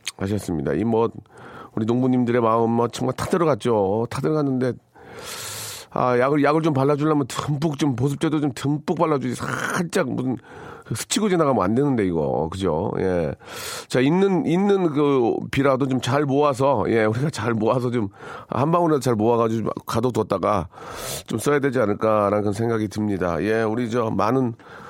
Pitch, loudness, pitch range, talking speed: 125 Hz, -22 LUFS, 115-150 Hz, 335 characters per minute